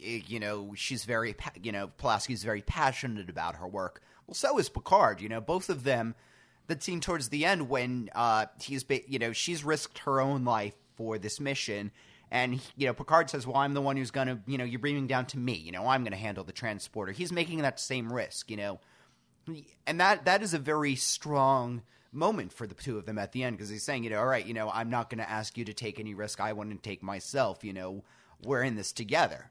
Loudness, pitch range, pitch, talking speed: -32 LUFS, 105-140 Hz, 120 Hz, 245 wpm